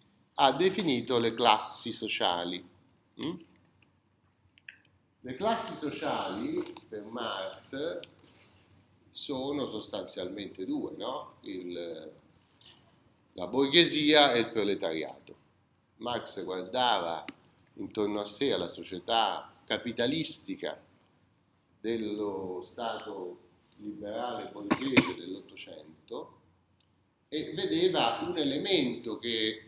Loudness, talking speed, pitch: -30 LUFS, 80 wpm, 115 Hz